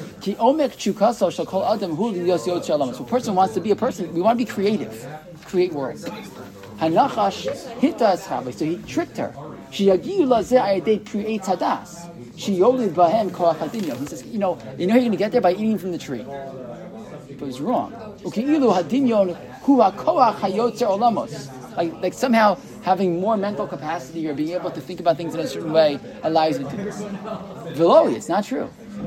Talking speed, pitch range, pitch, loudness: 125 wpm, 170-220 Hz, 190 Hz, -21 LUFS